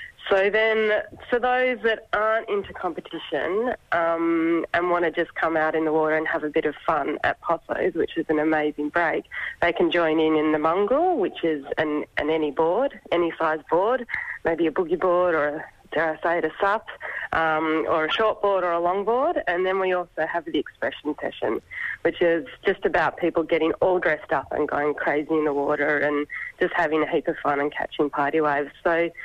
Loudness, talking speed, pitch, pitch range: -23 LUFS, 210 wpm, 165 Hz, 155-195 Hz